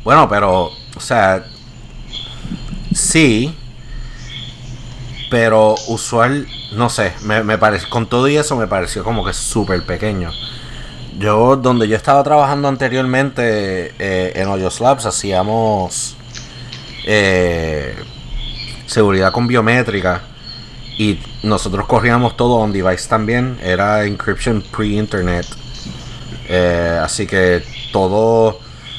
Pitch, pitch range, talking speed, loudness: 115 Hz, 100-125 Hz, 105 wpm, -15 LUFS